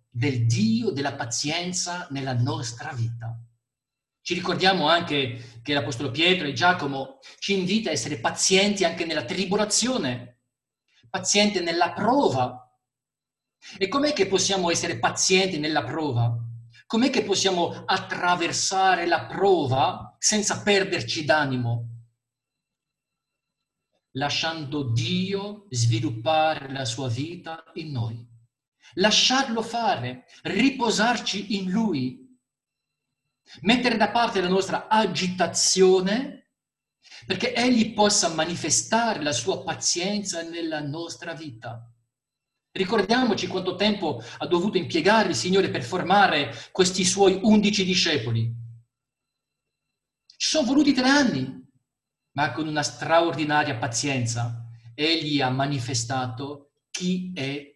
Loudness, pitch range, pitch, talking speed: -23 LUFS, 130-190 Hz, 160 Hz, 105 wpm